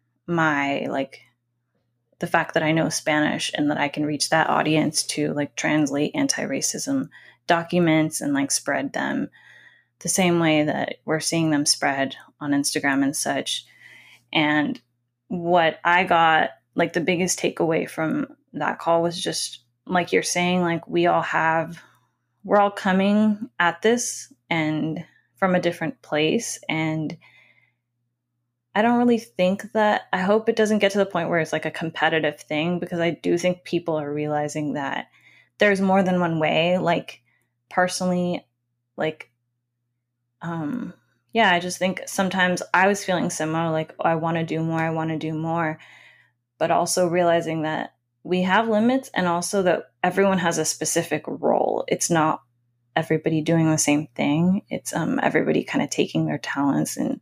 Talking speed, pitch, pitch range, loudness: 165 wpm, 165 Hz, 150-180 Hz, -22 LUFS